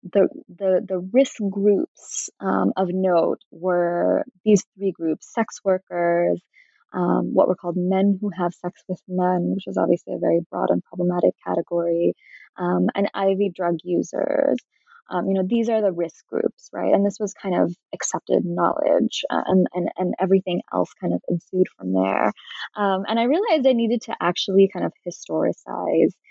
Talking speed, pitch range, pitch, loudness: 175 wpm, 175-200 Hz, 185 Hz, -22 LUFS